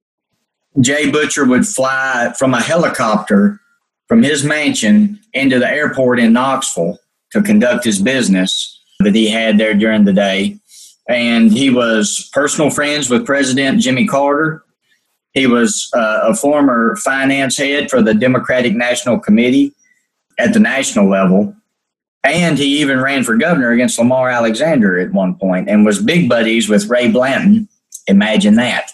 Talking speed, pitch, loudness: 150 wpm, 140 Hz, -13 LUFS